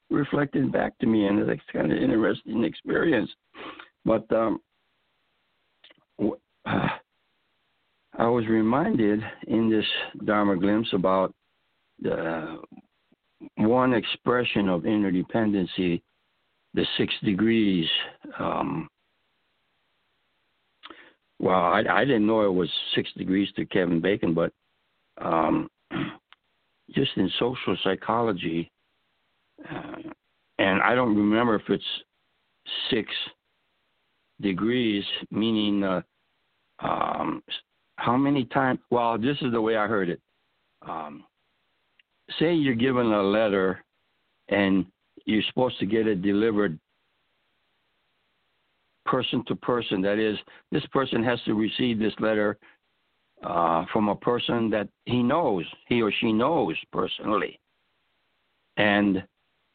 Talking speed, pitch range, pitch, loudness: 110 wpm, 100-115 Hz, 105 Hz, -25 LUFS